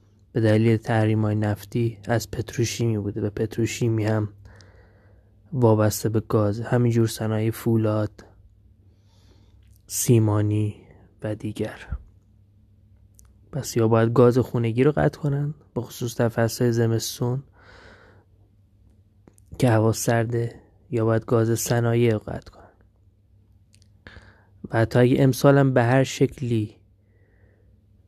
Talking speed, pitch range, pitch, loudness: 105 wpm, 100-115 Hz, 105 Hz, -23 LUFS